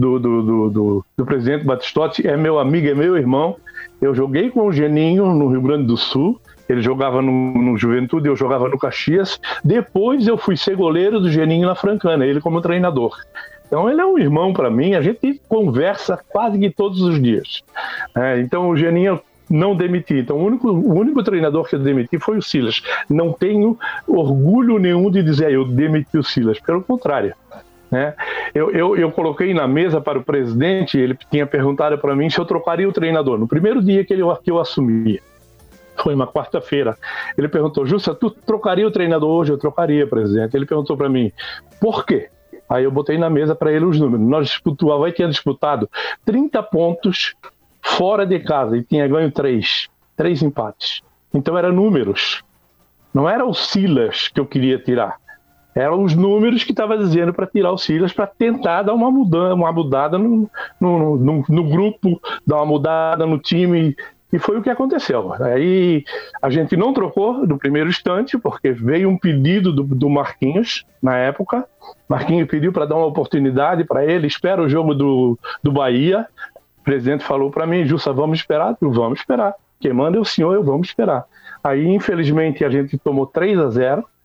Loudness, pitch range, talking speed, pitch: -17 LUFS, 140-195 Hz, 190 wpm, 165 Hz